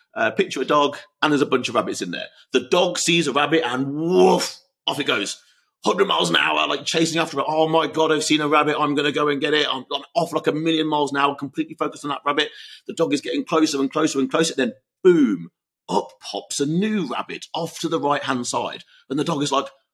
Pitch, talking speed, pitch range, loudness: 150 Hz, 260 wpm, 145-165 Hz, -21 LUFS